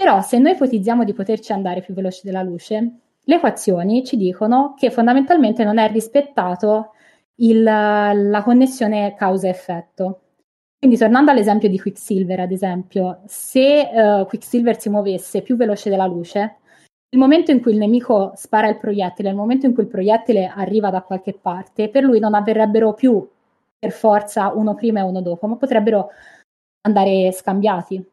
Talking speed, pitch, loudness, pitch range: 160 wpm, 215 Hz, -17 LUFS, 195-235 Hz